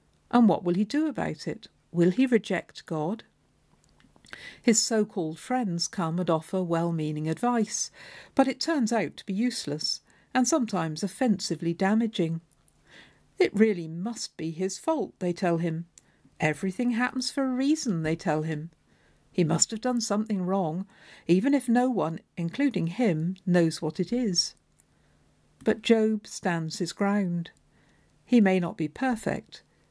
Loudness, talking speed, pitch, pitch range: -27 LUFS, 150 wpm, 195 Hz, 170-235 Hz